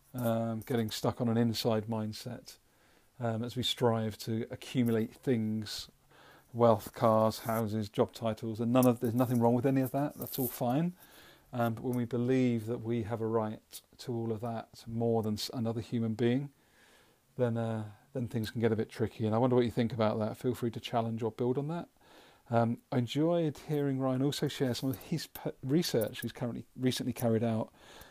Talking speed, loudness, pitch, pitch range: 205 wpm, -33 LUFS, 120 Hz, 115-130 Hz